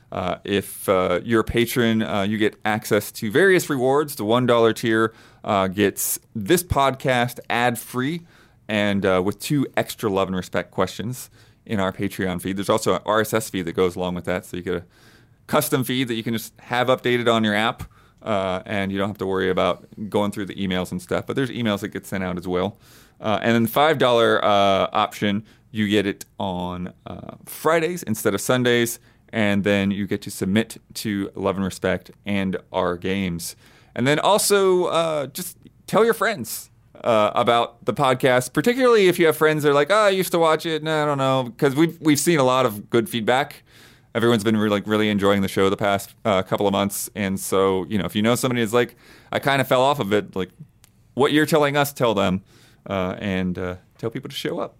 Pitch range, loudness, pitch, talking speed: 100-130 Hz, -21 LUFS, 115 Hz, 215 wpm